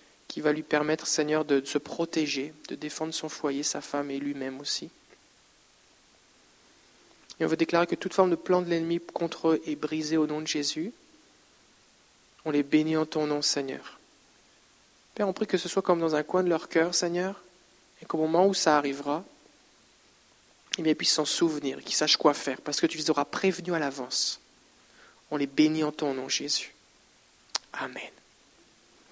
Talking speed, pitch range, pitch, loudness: 185 wpm, 150-170 Hz, 155 Hz, -28 LUFS